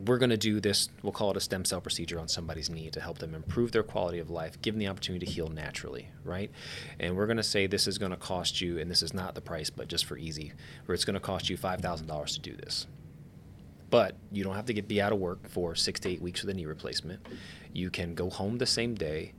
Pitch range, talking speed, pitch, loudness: 85-100 Hz, 270 wpm, 90 Hz, -32 LUFS